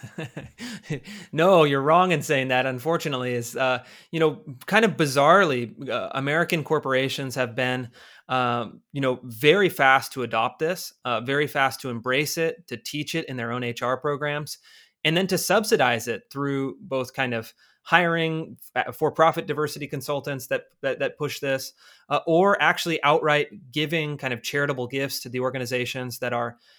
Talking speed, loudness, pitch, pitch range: 165 wpm, -24 LUFS, 140 Hz, 125-160 Hz